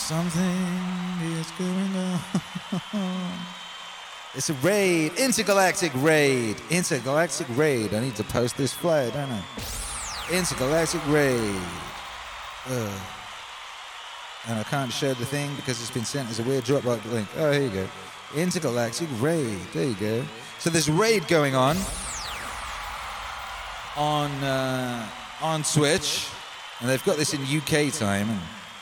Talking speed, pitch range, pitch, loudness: 130 wpm, 120-170 Hz, 145 Hz, -26 LUFS